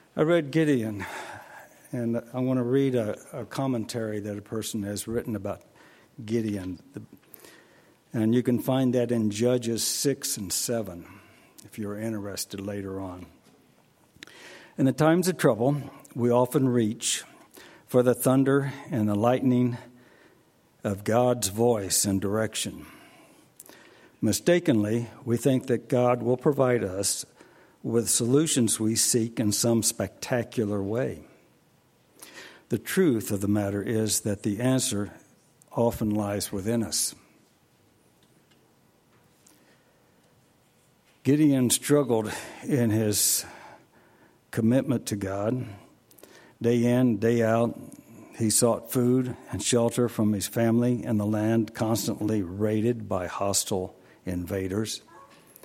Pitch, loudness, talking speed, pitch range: 115 Hz, -26 LUFS, 115 wpm, 105-125 Hz